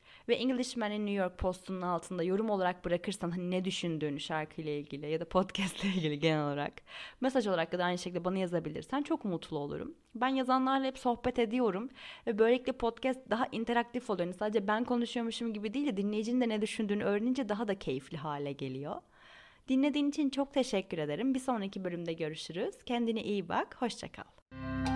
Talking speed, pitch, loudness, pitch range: 175 wpm, 205 Hz, -34 LUFS, 175-245 Hz